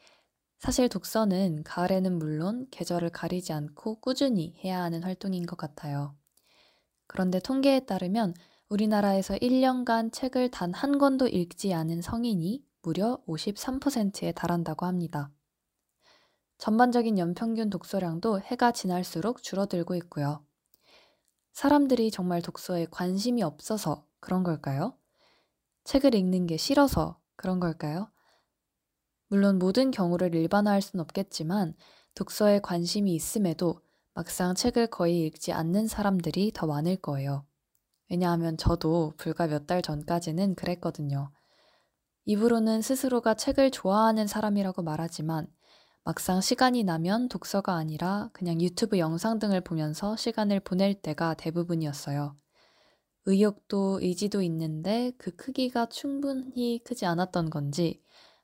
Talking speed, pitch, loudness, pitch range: 290 characters per minute, 185 Hz, -29 LUFS, 170-220 Hz